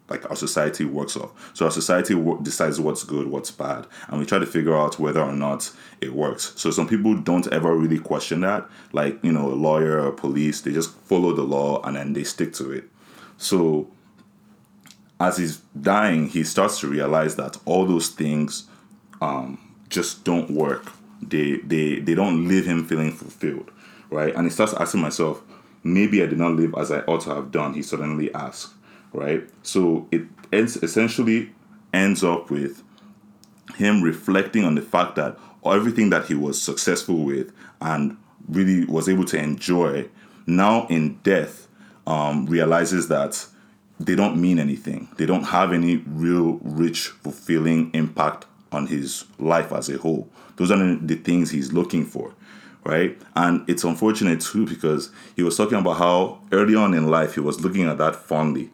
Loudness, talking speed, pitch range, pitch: -22 LUFS, 175 wpm, 75-90 Hz, 80 Hz